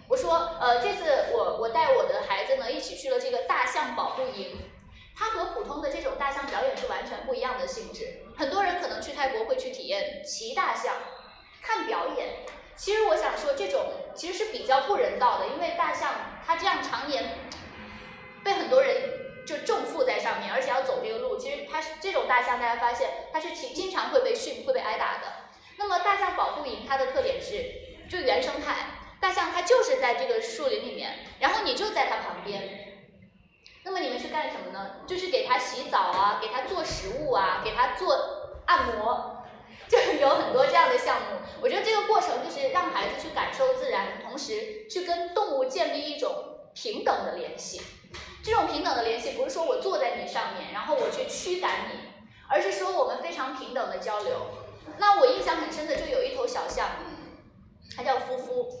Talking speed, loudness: 290 characters per minute, -28 LUFS